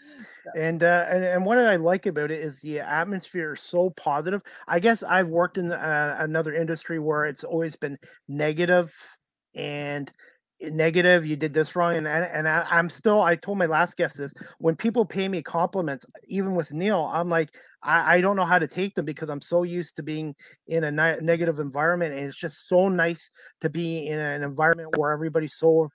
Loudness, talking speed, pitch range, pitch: -24 LUFS, 200 wpm, 155-180 Hz, 165 Hz